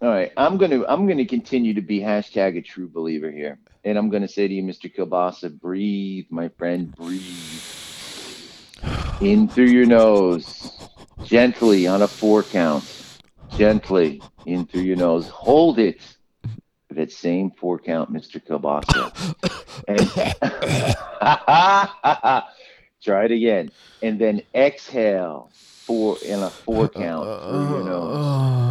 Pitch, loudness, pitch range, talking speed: 100 Hz, -20 LUFS, 90-115 Hz, 130 wpm